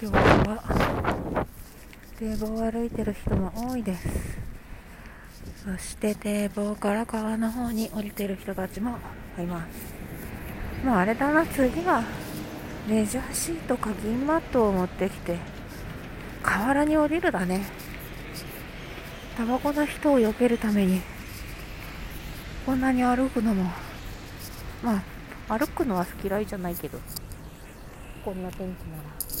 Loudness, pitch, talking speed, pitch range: -27 LUFS, 215 Hz, 235 characters per minute, 190-245 Hz